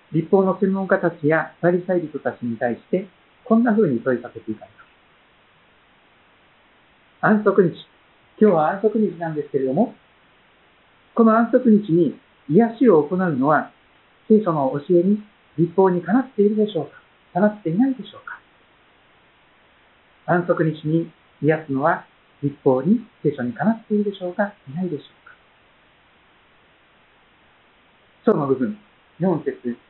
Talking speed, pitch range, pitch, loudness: 280 characters per minute, 150-210 Hz, 180 Hz, -20 LUFS